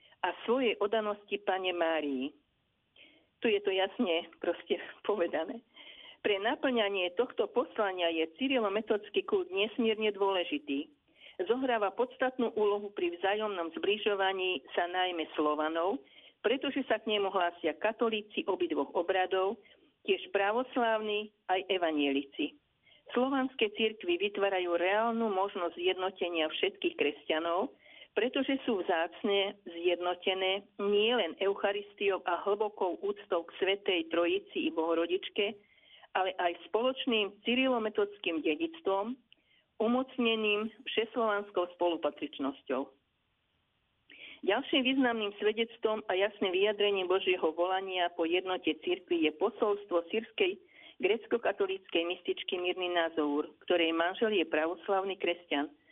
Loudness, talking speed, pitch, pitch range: -32 LUFS, 100 wpm, 205 Hz, 175-235 Hz